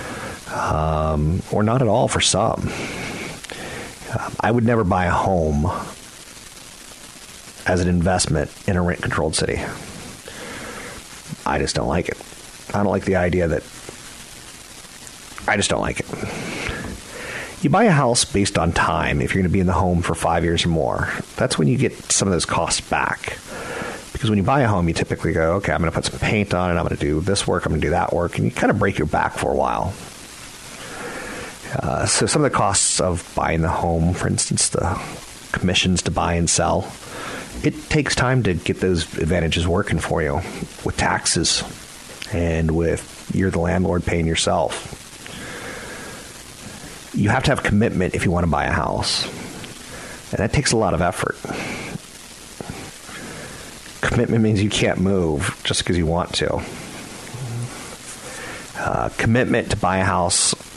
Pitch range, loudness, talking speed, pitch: 85-100 Hz, -20 LUFS, 175 wpm, 90 Hz